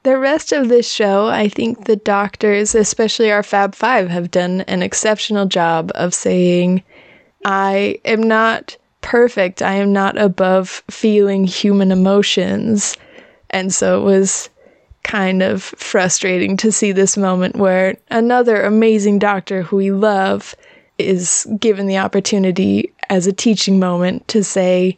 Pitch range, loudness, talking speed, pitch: 190-215 Hz, -15 LUFS, 140 wpm, 200 Hz